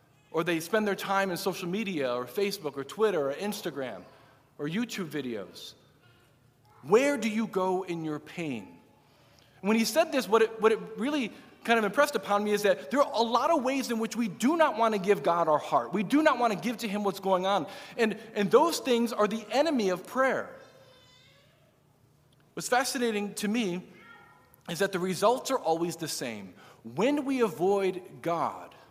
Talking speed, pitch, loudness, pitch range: 195 wpm, 195 Hz, -28 LUFS, 150-225 Hz